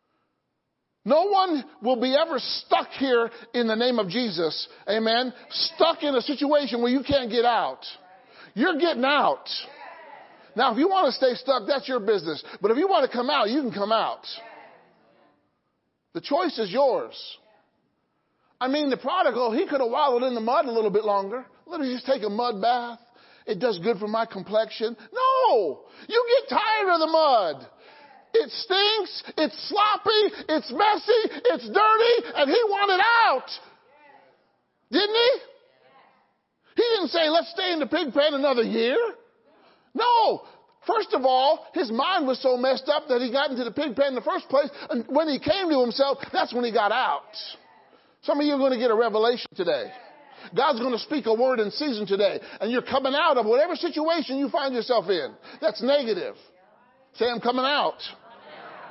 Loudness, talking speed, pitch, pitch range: -24 LUFS, 180 wpm, 280 Hz, 240-360 Hz